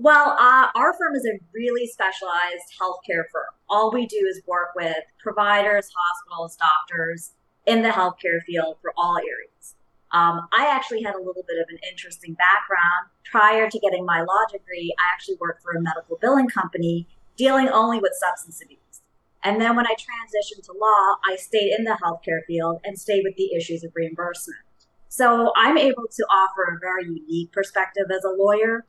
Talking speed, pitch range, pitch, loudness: 185 wpm, 170-220 Hz, 190 Hz, -21 LUFS